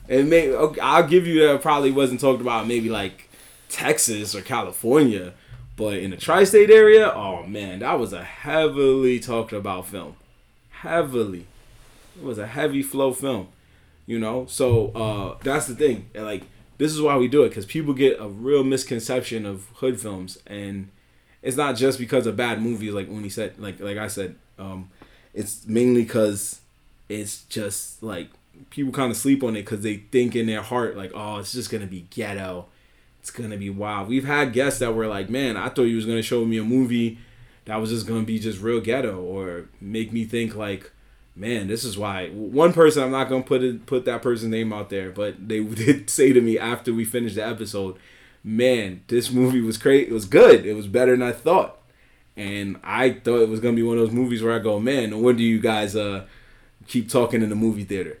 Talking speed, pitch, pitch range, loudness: 210 wpm, 115 Hz, 105-125 Hz, -21 LUFS